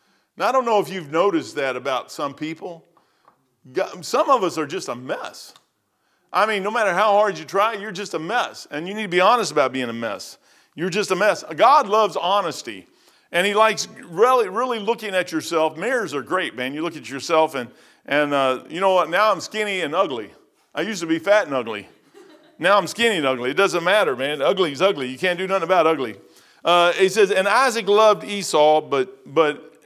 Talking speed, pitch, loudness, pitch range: 220 wpm, 195 Hz, -20 LUFS, 160-220 Hz